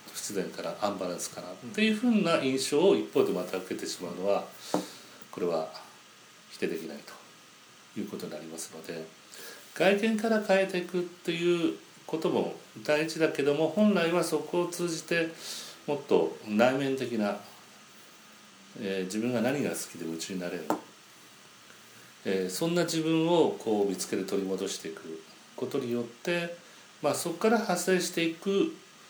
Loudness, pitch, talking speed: -30 LUFS, 160 Hz, 310 characters per minute